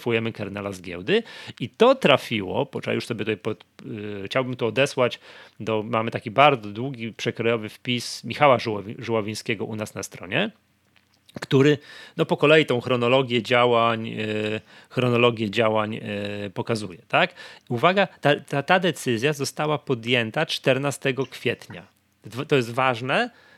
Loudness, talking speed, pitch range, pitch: -23 LUFS, 130 wpm, 110-135 Hz, 120 Hz